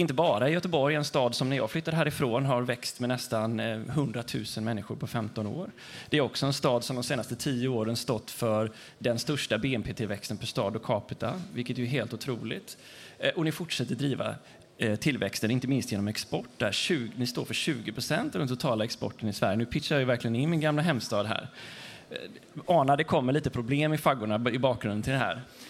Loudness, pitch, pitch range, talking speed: -29 LUFS, 125 Hz, 115-145 Hz, 205 wpm